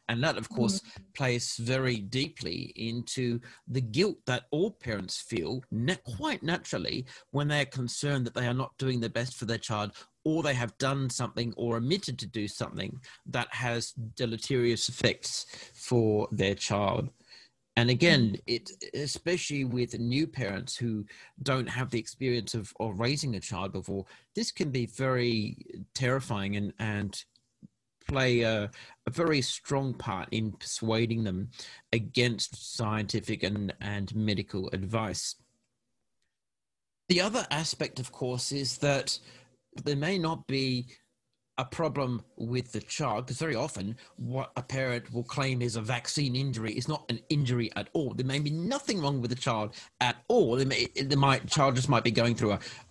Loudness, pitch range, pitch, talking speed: -31 LUFS, 110-135 Hz, 125 Hz, 160 wpm